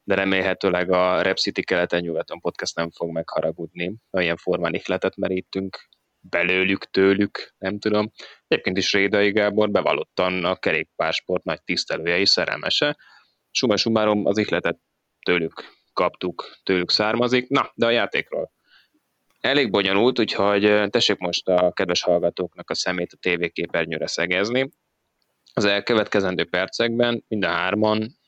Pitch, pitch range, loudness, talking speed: 95 Hz, 90-105 Hz, -22 LUFS, 130 wpm